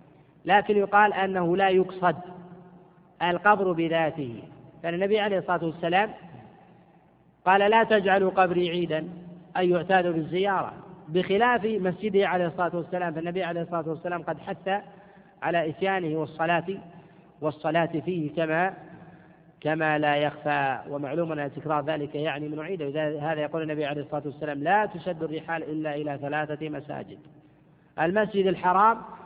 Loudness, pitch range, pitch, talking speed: -26 LUFS, 155-185 Hz, 170 Hz, 125 wpm